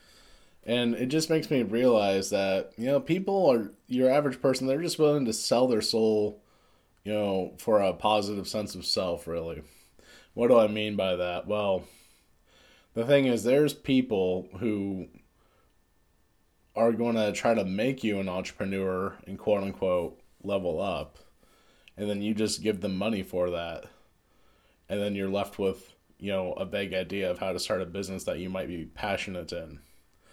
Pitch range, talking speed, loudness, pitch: 95-115 Hz, 175 wpm, -28 LUFS, 100 Hz